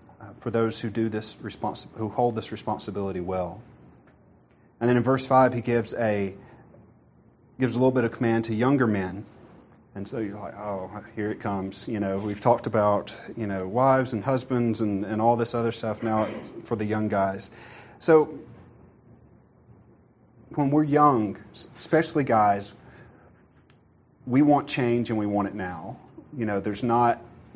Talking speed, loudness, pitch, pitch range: 170 wpm, -25 LUFS, 115 Hz, 105-120 Hz